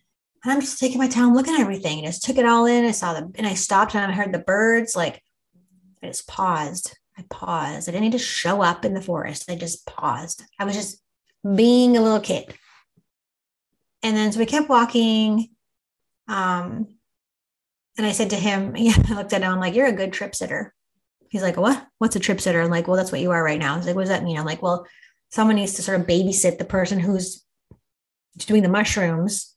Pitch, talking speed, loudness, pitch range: 200 Hz, 225 wpm, -21 LUFS, 180-225 Hz